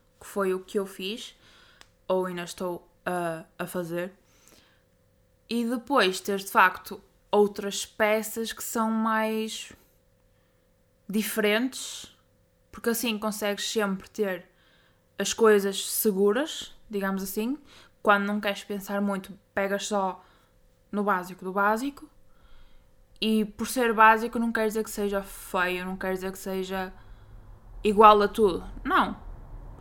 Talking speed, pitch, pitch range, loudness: 125 wpm, 205 Hz, 190-220 Hz, -26 LUFS